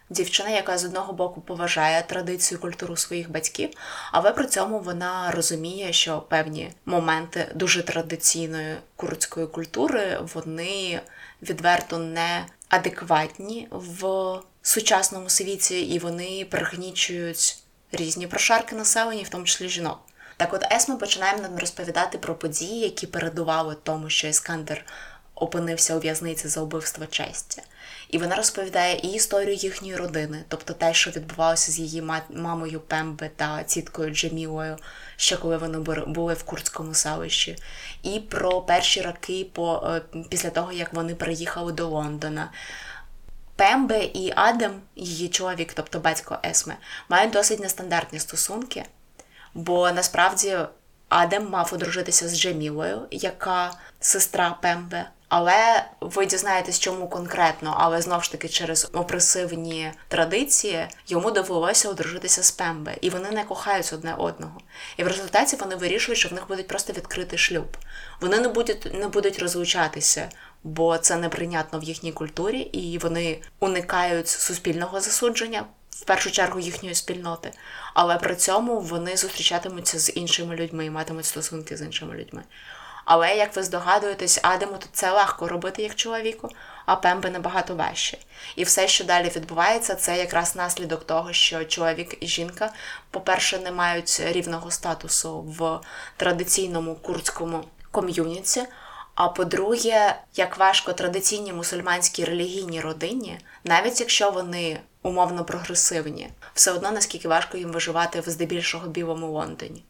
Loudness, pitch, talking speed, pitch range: -23 LUFS, 175 Hz, 135 wpm, 165-190 Hz